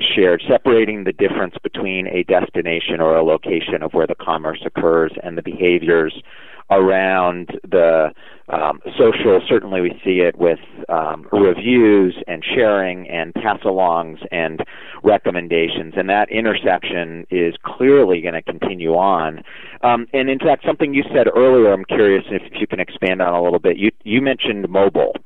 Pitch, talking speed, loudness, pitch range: 95 Hz, 165 wpm, -17 LUFS, 85-105 Hz